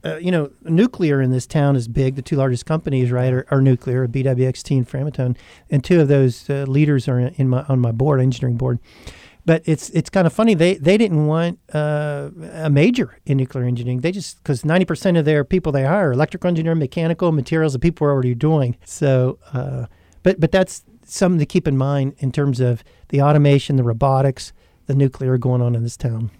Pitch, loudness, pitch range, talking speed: 140 Hz, -18 LUFS, 130-160 Hz, 210 wpm